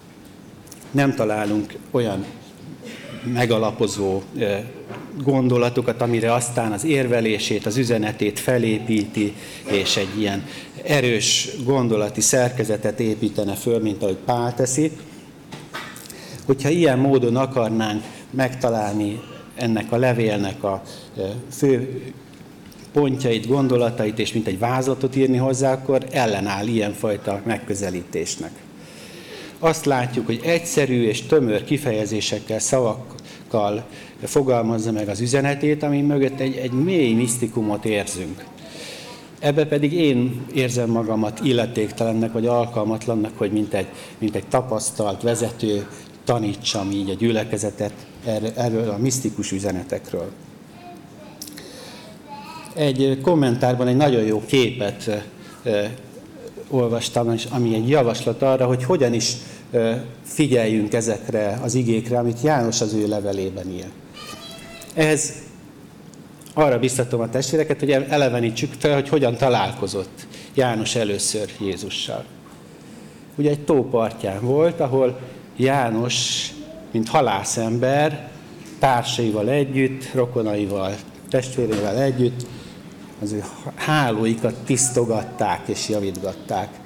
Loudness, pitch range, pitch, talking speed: -21 LUFS, 105-130 Hz, 120 Hz, 100 wpm